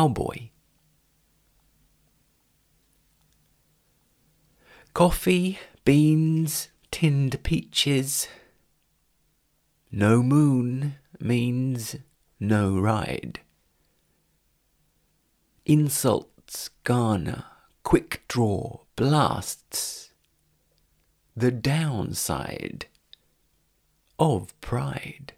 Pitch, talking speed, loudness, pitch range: 135 Hz, 45 wpm, -25 LUFS, 115-150 Hz